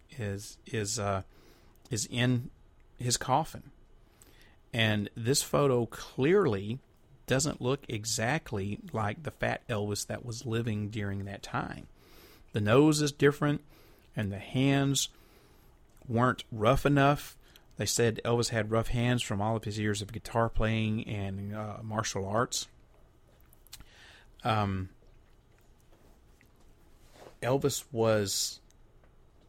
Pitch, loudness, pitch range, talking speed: 115 Hz, -30 LUFS, 105-125 Hz, 110 wpm